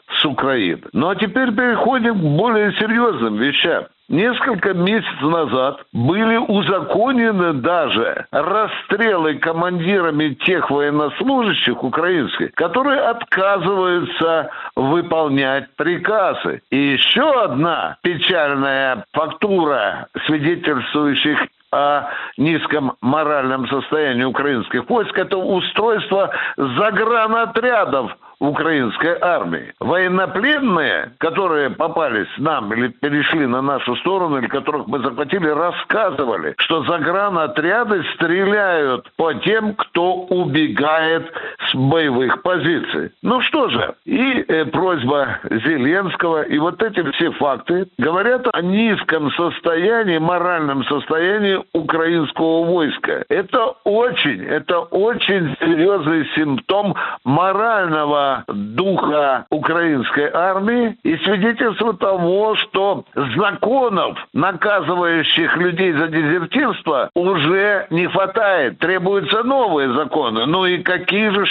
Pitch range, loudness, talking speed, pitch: 155-205 Hz, -17 LUFS, 95 wpm, 175 Hz